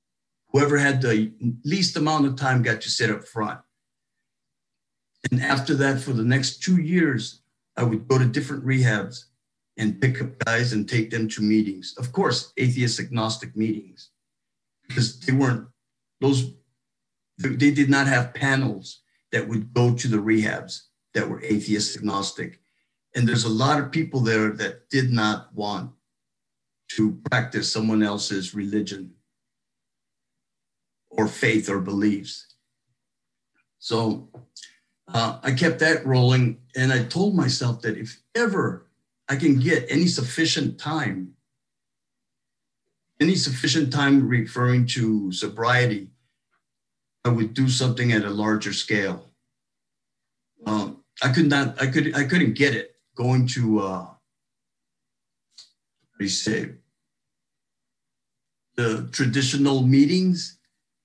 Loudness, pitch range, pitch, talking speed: -23 LUFS, 105-135 Hz, 120 Hz, 125 wpm